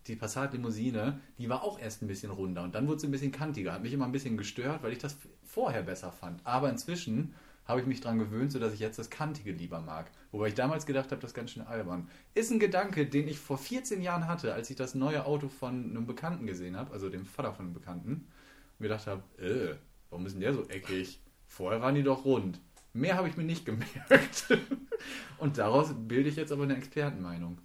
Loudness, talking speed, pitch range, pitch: -34 LUFS, 230 wpm, 105-145 Hz, 130 Hz